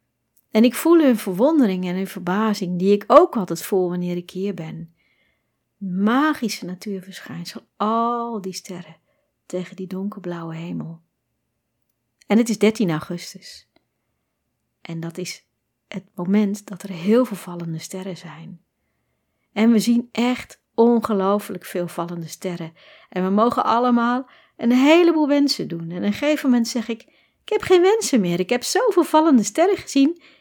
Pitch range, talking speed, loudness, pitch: 175-240 Hz, 150 wpm, -20 LUFS, 200 Hz